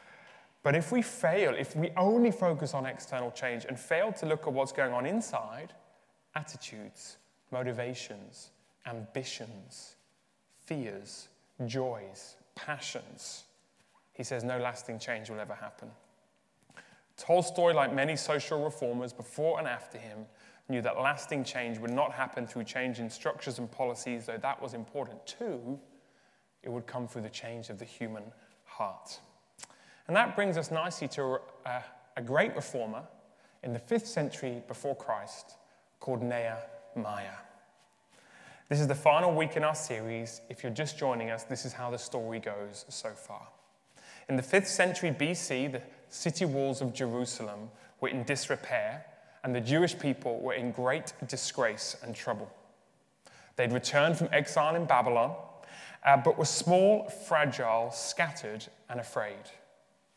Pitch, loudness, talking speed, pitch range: 130 Hz, -32 LUFS, 145 wpm, 120-150 Hz